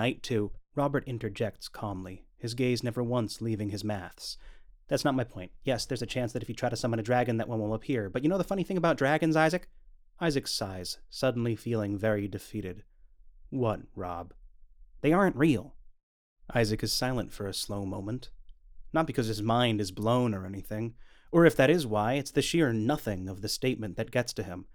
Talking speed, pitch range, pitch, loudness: 200 wpm, 100-125 Hz, 115 Hz, -30 LUFS